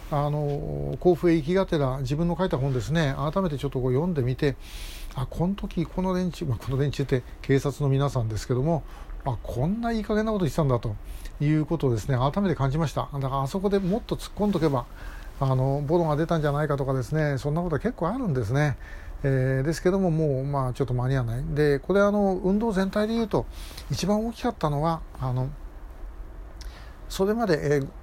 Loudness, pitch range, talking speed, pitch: -26 LUFS, 130-175 Hz, 415 characters per minute, 145 Hz